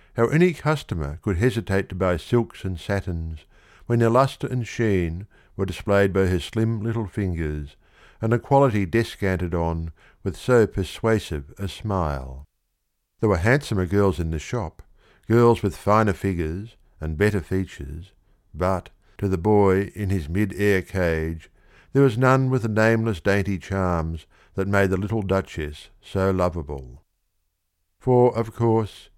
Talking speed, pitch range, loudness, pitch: 150 wpm, 85-110 Hz, -23 LUFS, 95 Hz